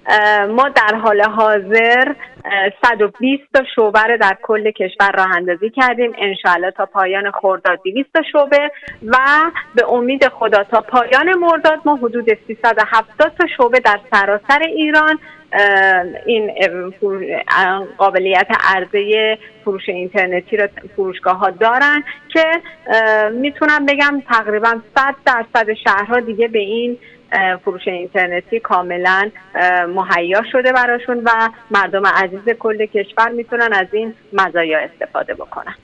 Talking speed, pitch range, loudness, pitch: 120 wpm, 195-250 Hz, -14 LUFS, 220 Hz